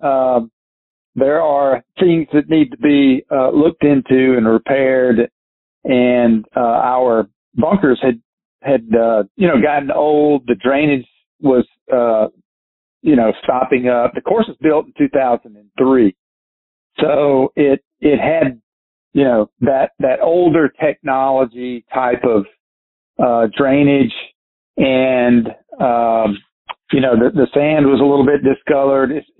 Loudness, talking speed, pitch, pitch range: -14 LUFS, 135 wpm, 130 Hz, 115-140 Hz